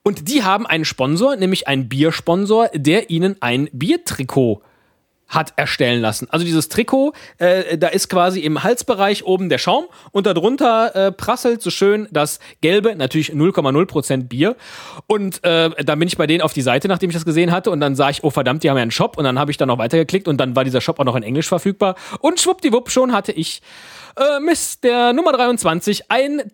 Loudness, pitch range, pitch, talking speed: -17 LUFS, 150-215 Hz, 175 Hz, 205 wpm